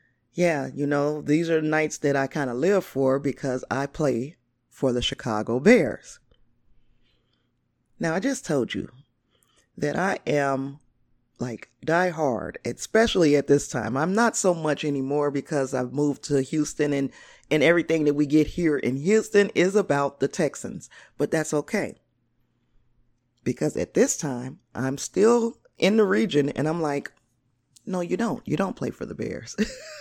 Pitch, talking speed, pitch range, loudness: 140 Hz, 160 wpm, 125-155 Hz, -24 LUFS